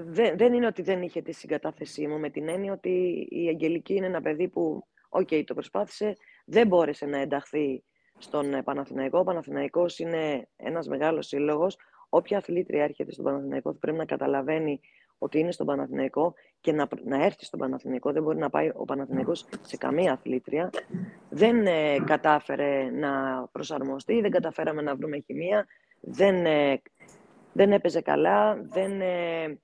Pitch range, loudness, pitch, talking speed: 145-185 Hz, -27 LUFS, 160 Hz, 150 wpm